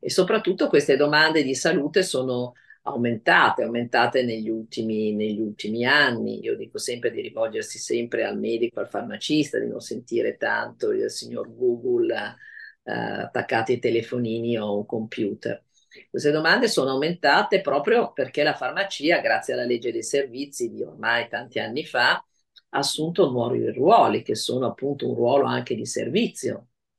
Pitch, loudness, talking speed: 150 Hz, -23 LUFS, 155 wpm